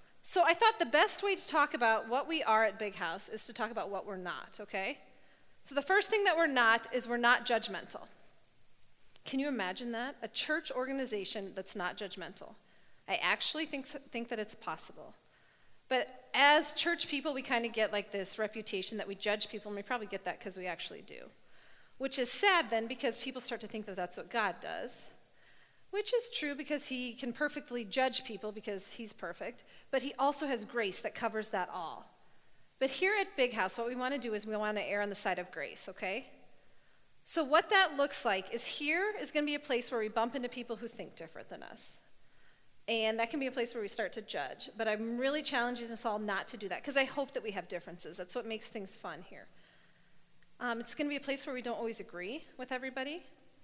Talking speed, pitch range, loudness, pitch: 220 wpm, 215-285 Hz, -34 LUFS, 240 Hz